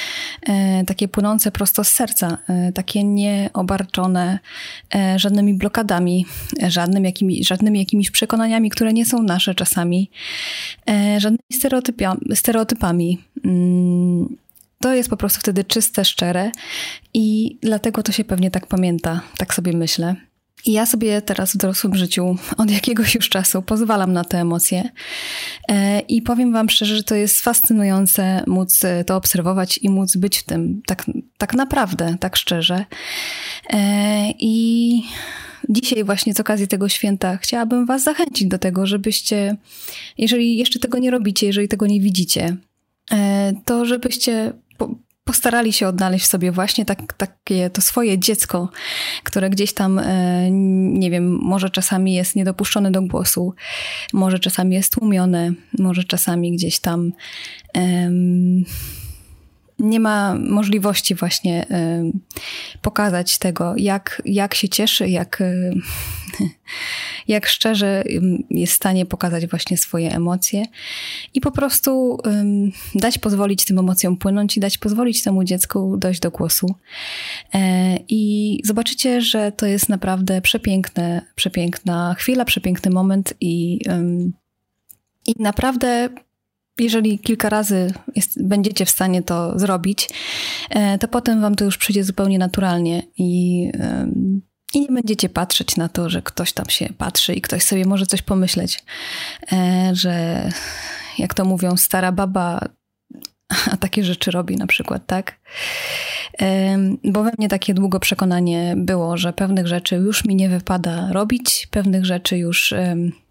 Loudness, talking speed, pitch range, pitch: -18 LUFS, 130 wpm, 185-225 Hz, 195 Hz